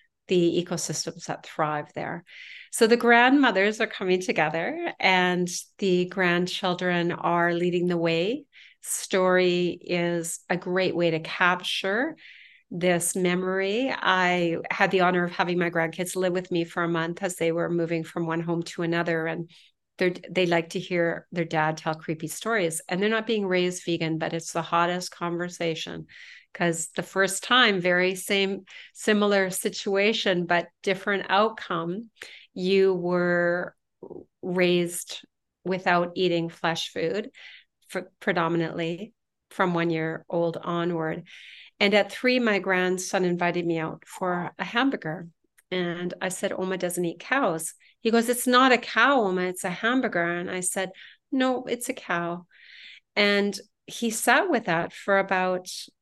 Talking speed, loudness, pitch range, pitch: 150 wpm, -25 LUFS, 170-195 Hz, 180 Hz